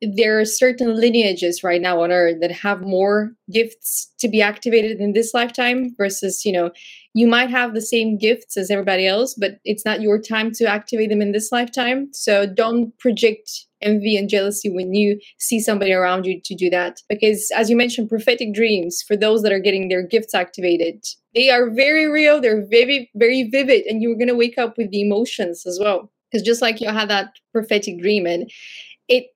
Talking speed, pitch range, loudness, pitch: 200 wpm, 200-235 Hz, -18 LUFS, 215 Hz